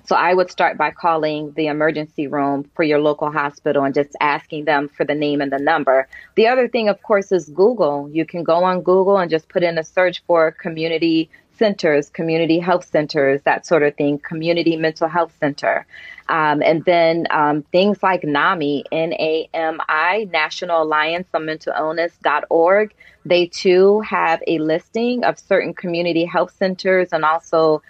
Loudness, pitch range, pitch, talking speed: -18 LUFS, 150-180 Hz, 165 Hz, 175 wpm